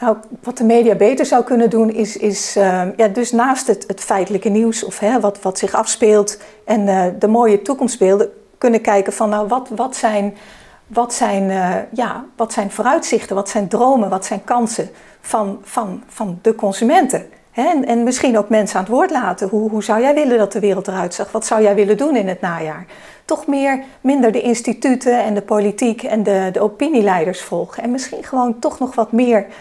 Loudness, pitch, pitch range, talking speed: -16 LUFS, 220 Hz, 205-240 Hz, 205 wpm